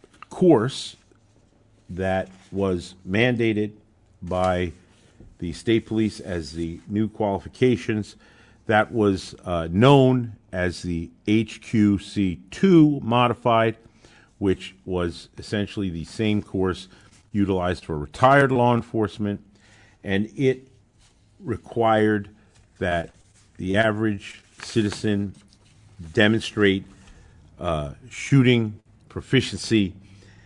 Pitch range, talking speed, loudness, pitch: 95-110 Hz, 85 wpm, -23 LUFS, 105 Hz